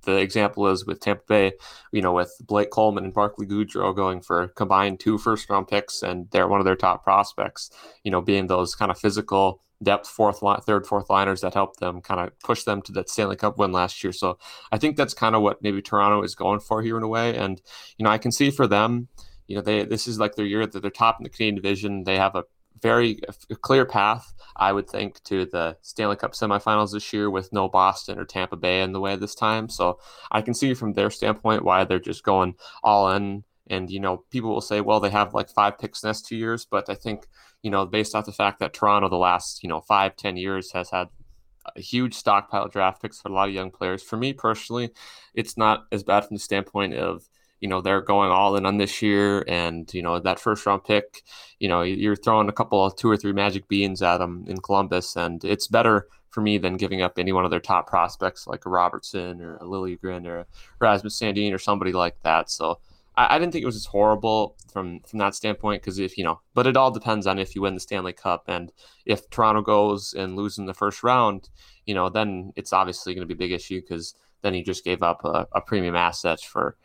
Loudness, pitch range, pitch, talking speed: -23 LUFS, 95-105 Hz, 100 Hz, 245 wpm